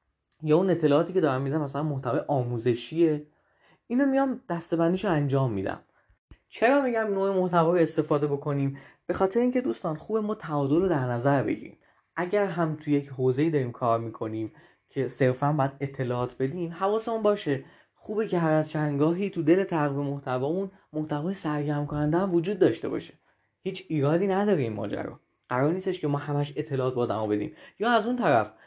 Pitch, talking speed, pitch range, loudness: 155 Hz, 170 wpm, 140-185 Hz, -27 LUFS